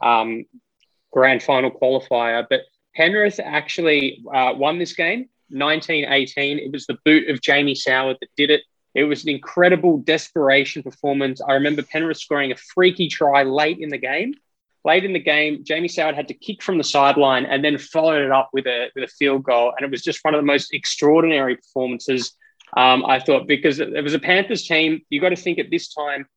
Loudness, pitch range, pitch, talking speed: -19 LUFS, 135-160 Hz, 145 Hz, 205 wpm